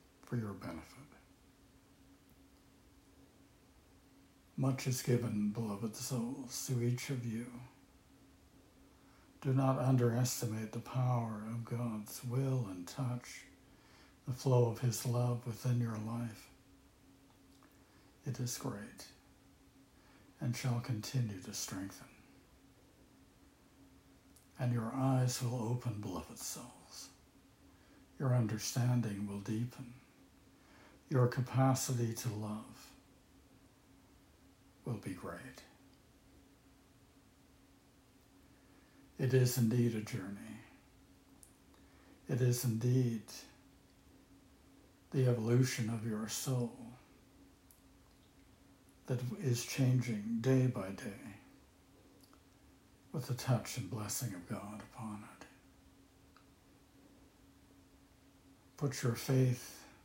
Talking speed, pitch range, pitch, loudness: 85 wpm, 110-130 Hz, 120 Hz, -37 LUFS